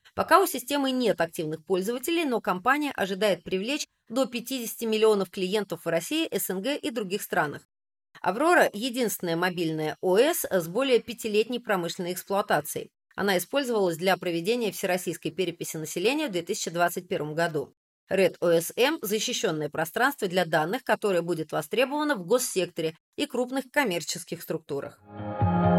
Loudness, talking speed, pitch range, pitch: -27 LUFS, 125 wpm, 170-235 Hz, 190 Hz